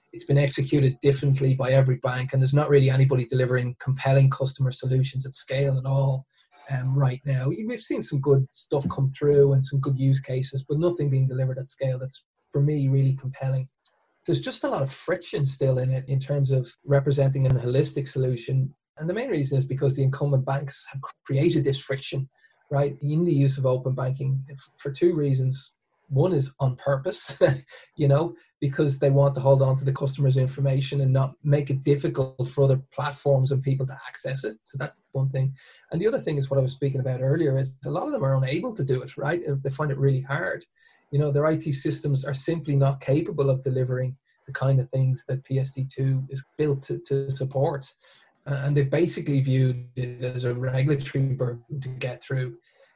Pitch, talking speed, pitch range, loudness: 135 Hz, 205 wpm, 130-140 Hz, -25 LUFS